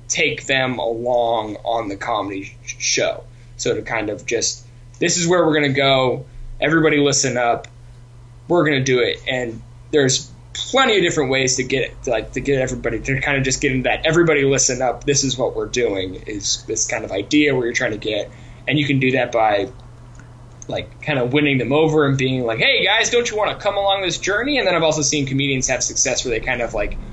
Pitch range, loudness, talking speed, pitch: 120-150 Hz, -18 LUFS, 230 wpm, 130 Hz